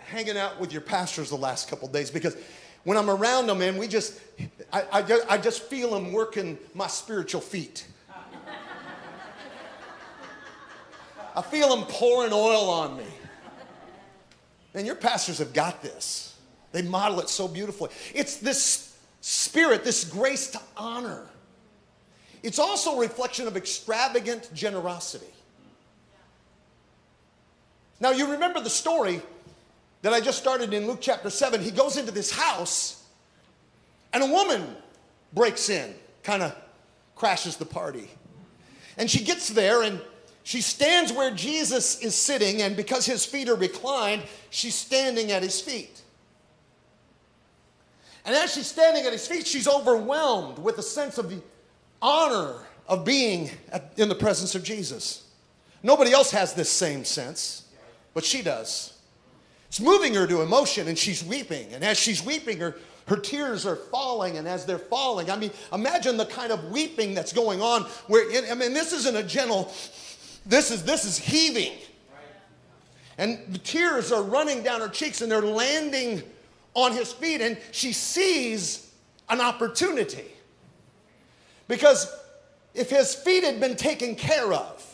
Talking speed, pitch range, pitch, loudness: 150 wpm, 200-275 Hz, 235 Hz, -25 LUFS